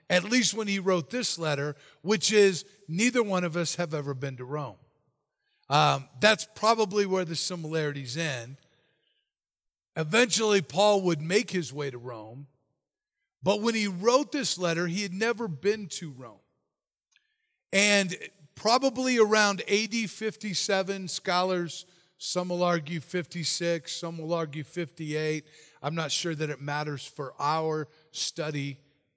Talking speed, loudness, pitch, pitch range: 140 wpm, -27 LUFS, 175 Hz, 150-205 Hz